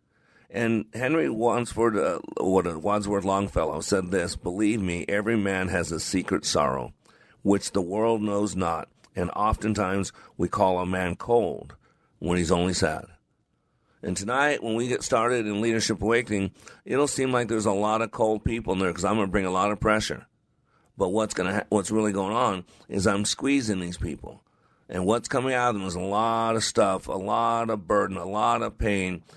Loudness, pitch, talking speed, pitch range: -26 LUFS, 105 Hz, 195 wpm, 95-115 Hz